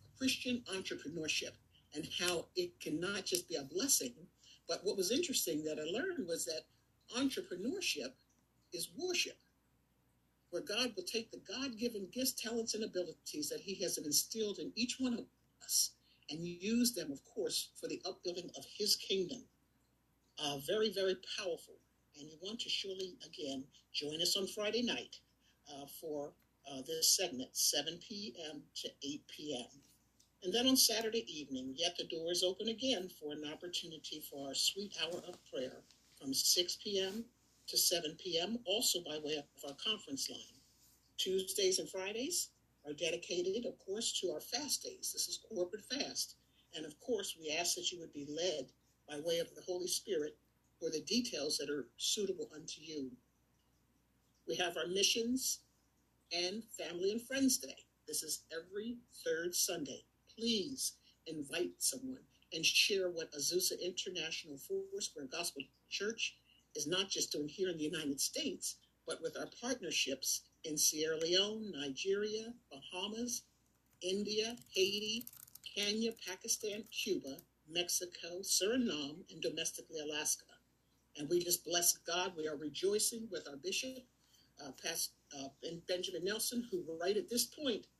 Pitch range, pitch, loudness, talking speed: 155-240 Hz, 185 Hz, -38 LUFS, 155 wpm